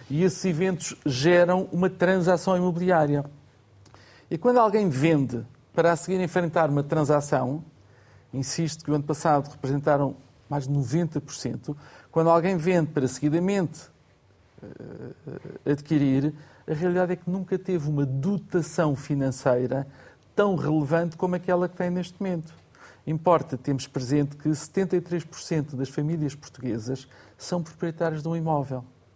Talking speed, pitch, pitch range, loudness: 130 wpm, 155 Hz, 140-175 Hz, -25 LUFS